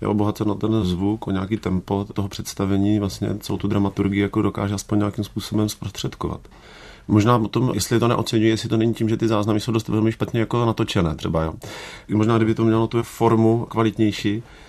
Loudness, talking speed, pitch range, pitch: -21 LUFS, 195 wpm, 100-115 Hz, 105 Hz